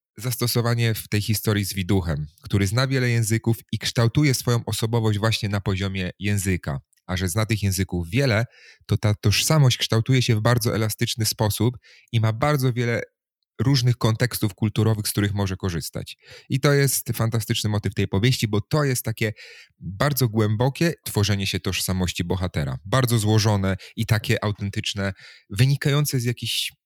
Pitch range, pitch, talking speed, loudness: 100-120 Hz, 110 Hz, 155 wpm, -23 LUFS